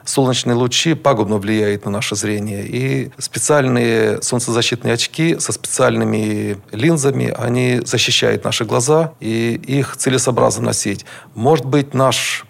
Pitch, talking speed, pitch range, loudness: 125 Hz, 120 wpm, 110-135 Hz, -16 LUFS